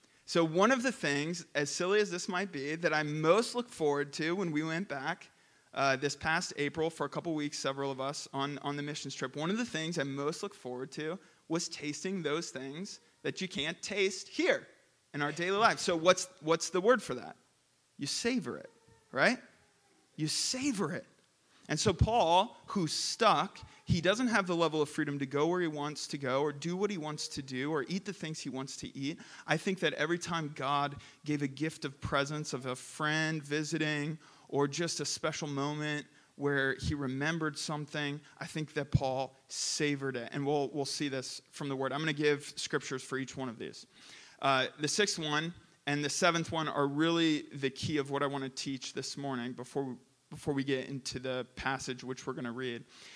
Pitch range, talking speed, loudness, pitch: 140-165 Hz, 210 wpm, -34 LUFS, 150 Hz